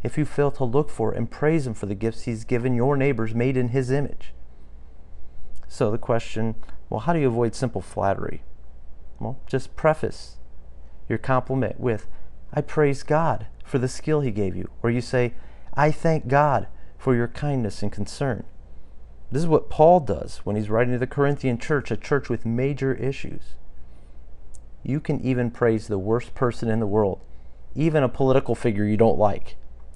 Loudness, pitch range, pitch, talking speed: -24 LUFS, 100-135 Hz, 120 Hz, 180 wpm